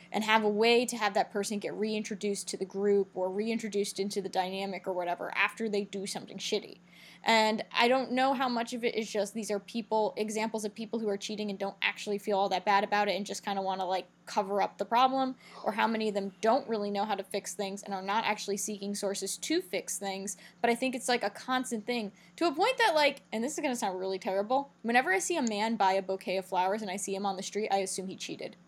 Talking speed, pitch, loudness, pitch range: 265 wpm, 205 Hz, -31 LUFS, 195-225 Hz